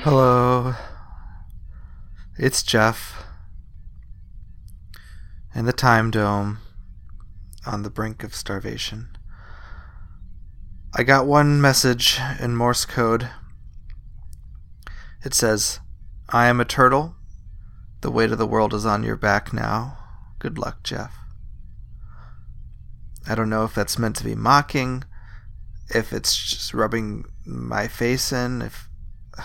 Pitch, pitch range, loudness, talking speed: 105 Hz, 90-120 Hz, -21 LUFS, 110 wpm